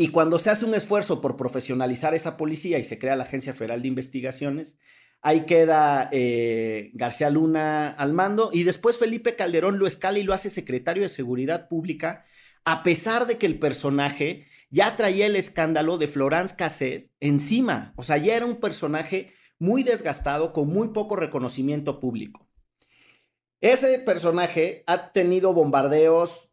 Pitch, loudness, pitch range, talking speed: 160 Hz, -24 LUFS, 140-190 Hz, 160 wpm